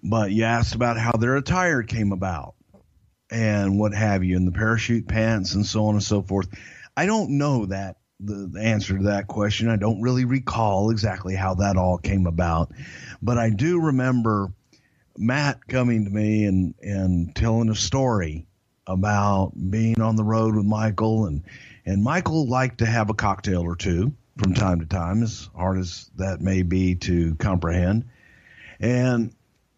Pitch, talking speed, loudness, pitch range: 105 Hz, 175 wpm, -23 LUFS, 95-115 Hz